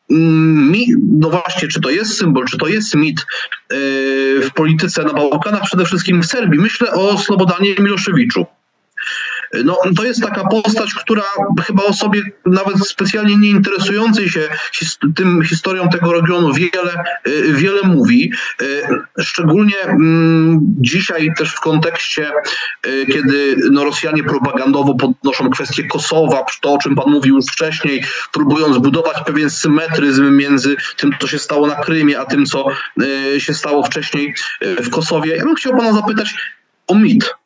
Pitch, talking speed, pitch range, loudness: 165 Hz, 140 wpm, 145-200 Hz, -14 LUFS